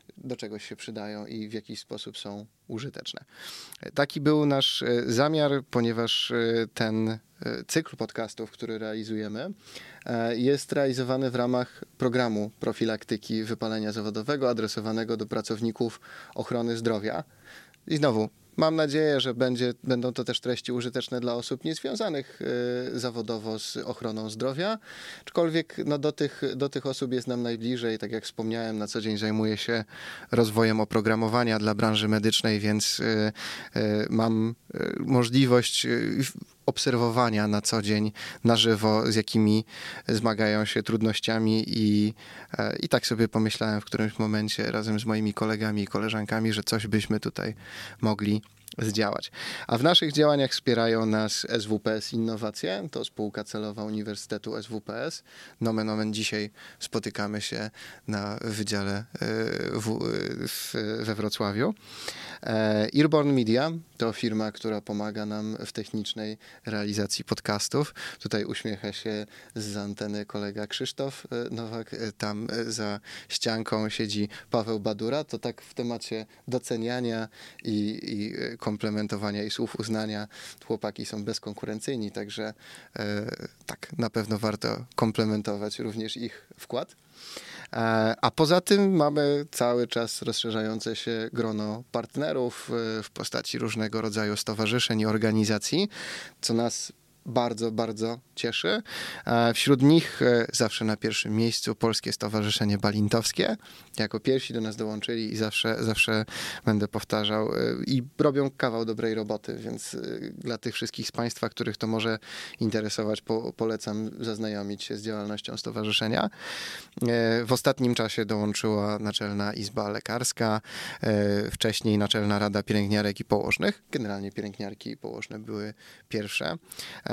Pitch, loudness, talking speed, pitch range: 110 Hz, -28 LUFS, 125 wpm, 105-120 Hz